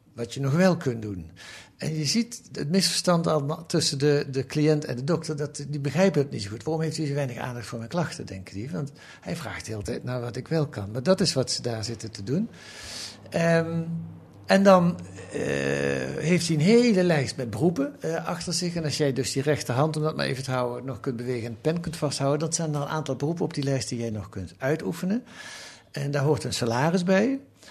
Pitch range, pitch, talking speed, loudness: 125-165 Hz, 150 Hz, 240 wpm, -26 LUFS